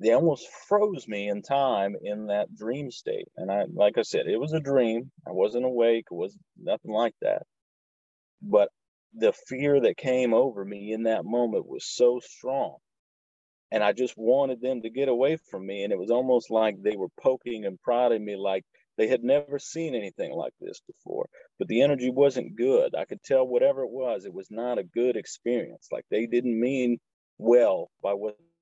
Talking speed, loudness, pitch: 195 wpm, -27 LUFS, 125 Hz